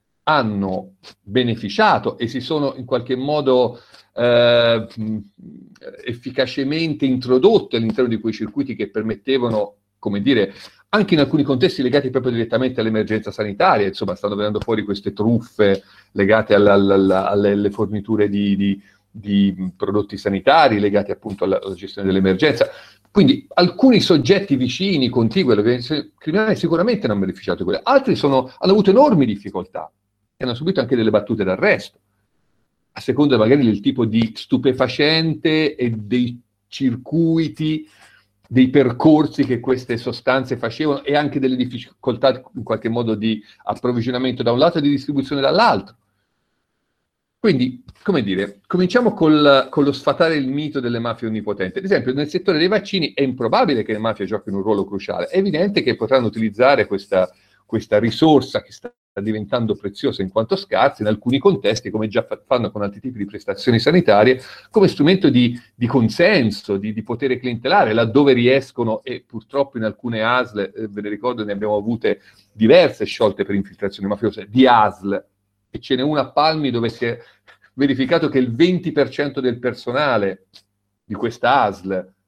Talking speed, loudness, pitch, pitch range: 150 wpm, -18 LUFS, 120 Hz, 105-140 Hz